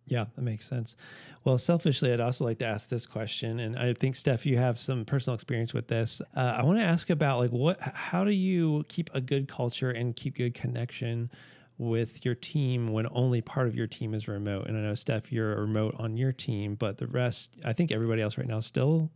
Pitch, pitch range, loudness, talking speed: 125 Hz, 115-140 Hz, -30 LUFS, 230 wpm